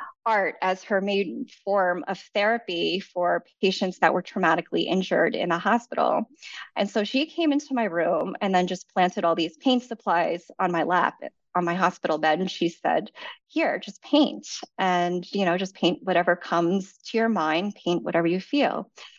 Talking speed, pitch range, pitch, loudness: 180 wpm, 175-225 Hz, 190 Hz, -25 LUFS